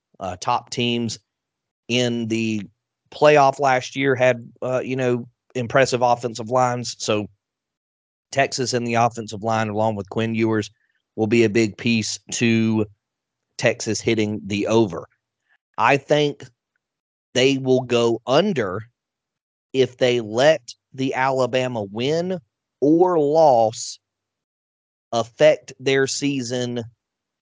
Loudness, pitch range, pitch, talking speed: -20 LUFS, 110-130 Hz, 120 Hz, 115 wpm